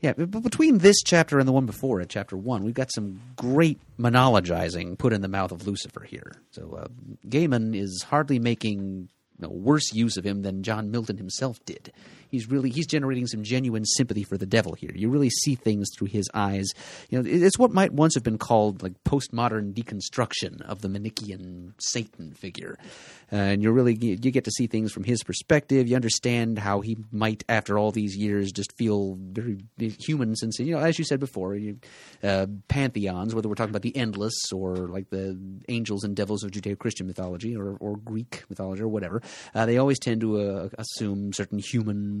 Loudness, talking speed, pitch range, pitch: -26 LUFS, 200 wpm, 100-125 Hz, 110 Hz